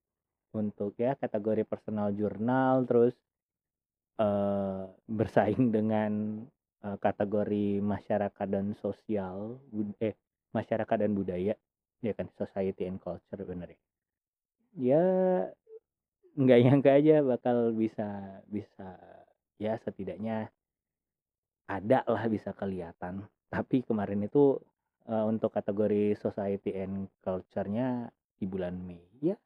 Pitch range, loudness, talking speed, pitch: 95-115 Hz, -31 LUFS, 105 wpm, 105 Hz